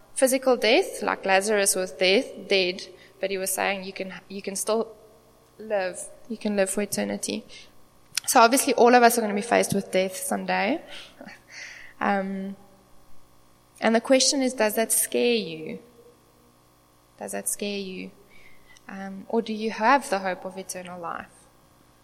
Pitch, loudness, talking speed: 195 Hz, -24 LUFS, 160 wpm